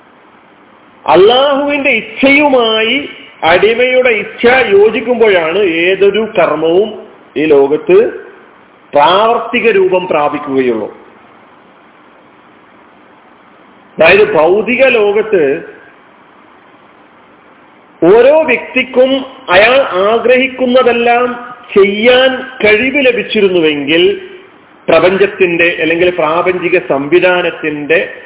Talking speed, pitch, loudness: 55 wpm, 245 Hz, -9 LUFS